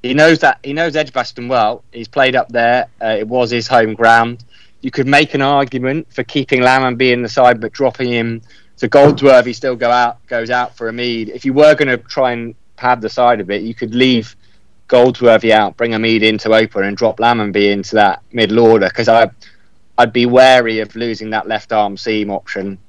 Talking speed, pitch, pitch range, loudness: 210 wpm, 120 Hz, 110-130 Hz, -13 LUFS